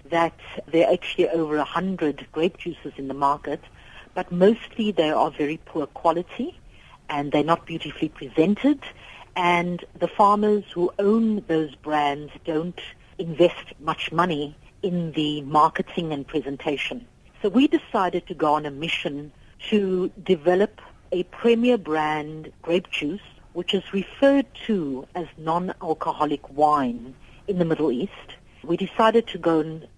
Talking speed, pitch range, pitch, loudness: 140 wpm, 150-190 Hz, 170 Hz, -24 LUFS